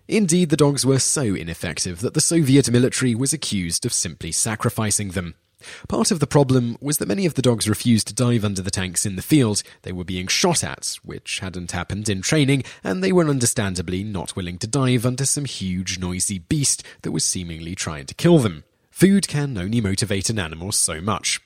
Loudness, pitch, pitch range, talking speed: -20 LUFS, 110 Hz, 95-135 Hz, 205 wpm